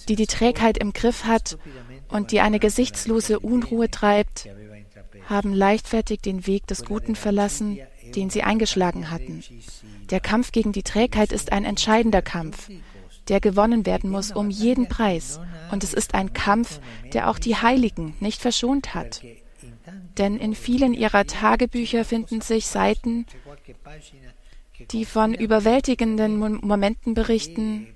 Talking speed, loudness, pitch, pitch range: 140 wpm, -22 LUFS, 210 Hz, 170-225 Hz